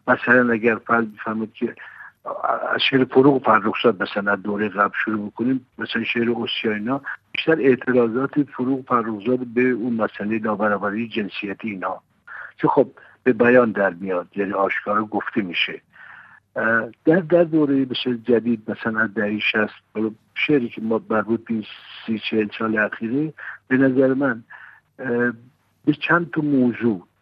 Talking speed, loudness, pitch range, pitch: 135 wpm, -21 LUFS, 110-130 Hz, 115 Hz